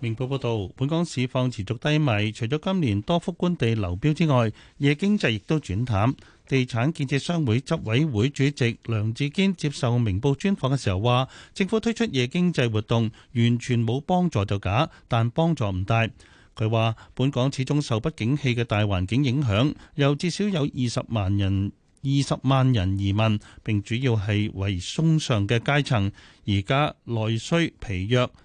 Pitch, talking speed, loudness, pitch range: 125 Hz, 255 characters per minute, -24 LUFS, 110-145 Hz